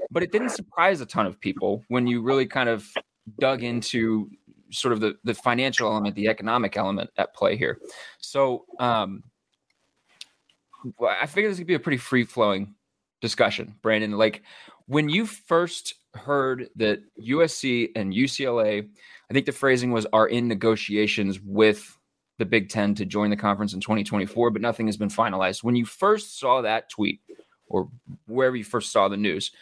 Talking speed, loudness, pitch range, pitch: 170 wpm, -24 LUFS, 105-135 Hz, 115 Hz